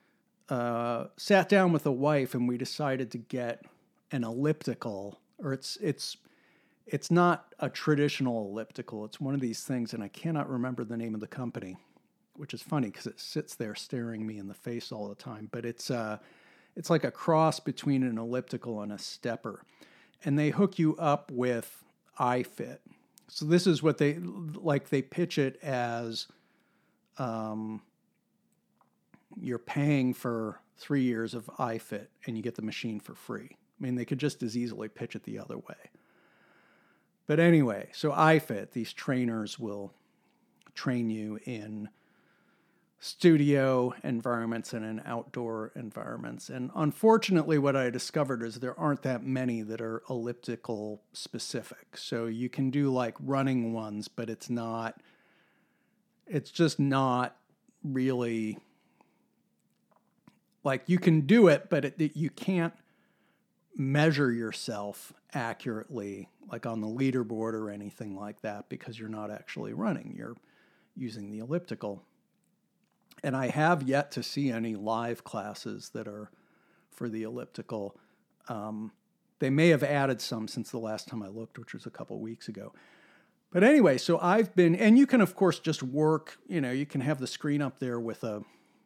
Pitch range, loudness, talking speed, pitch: 115-150 Hz, -30 LUFS, 160 wpm, 125 Hz